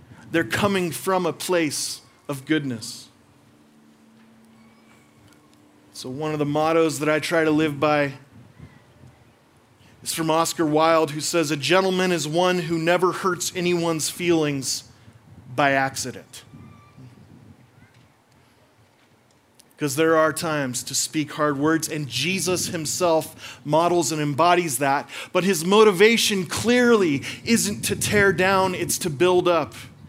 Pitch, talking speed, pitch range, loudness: 150 Hz, 125 wpm, 125-170 Hz, -21 LUFS